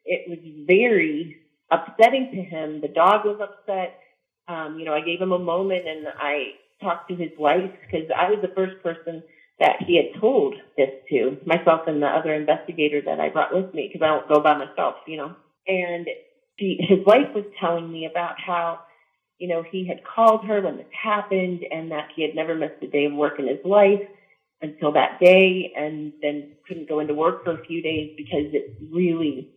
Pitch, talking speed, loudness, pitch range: 170 Hz, 205 wpm, -22 LUFS, 155-190 Hz